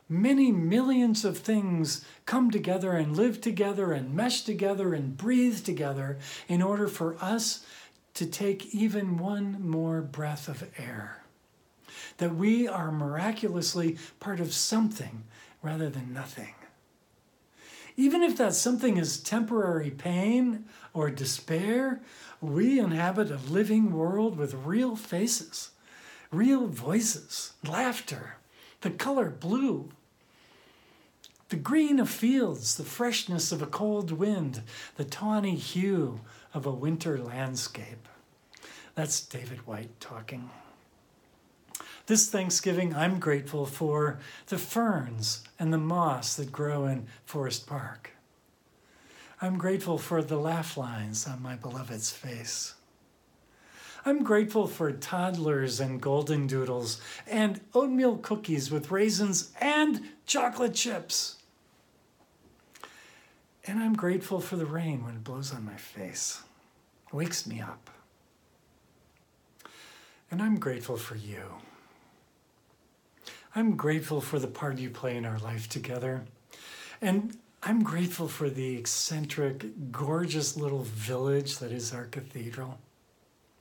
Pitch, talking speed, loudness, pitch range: 160 Hz, 120 wpm, -30 LUFS, 135-210 Hz